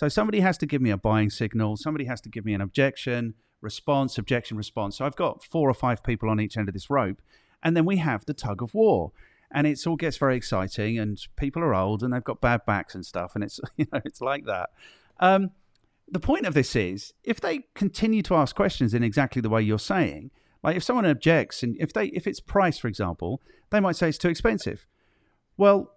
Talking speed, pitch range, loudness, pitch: 235 wpm, 110-165 Hz, -26 LUFS, 130 Hz